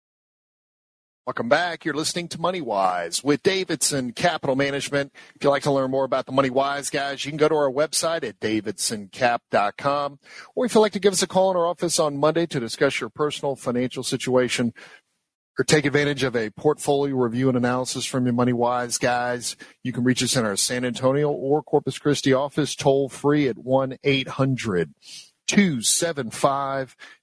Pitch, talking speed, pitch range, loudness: 140 Hz, 180 wpm, 130-150 Hz, -23 LUFS